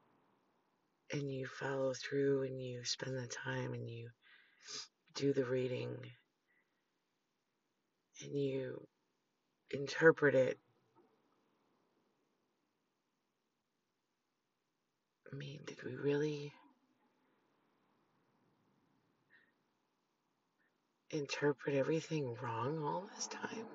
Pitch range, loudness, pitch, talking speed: 125-145 Hz, -39 LUFS, 135 Hz, 75 wpm